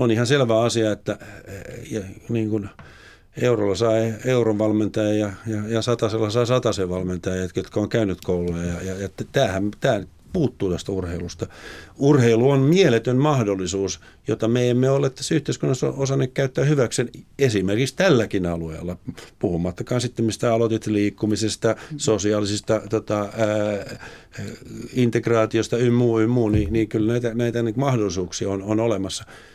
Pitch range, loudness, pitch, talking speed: 100-120 Hz, -22 LUFS, 110 Hz, 125 wpm